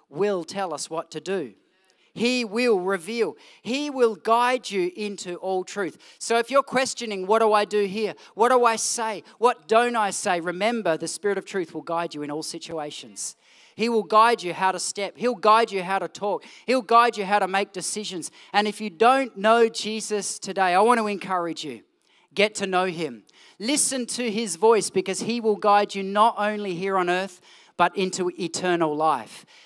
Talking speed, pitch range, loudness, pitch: 200 wpm, 185-230 Hz, -23 LUFS, 205 Hz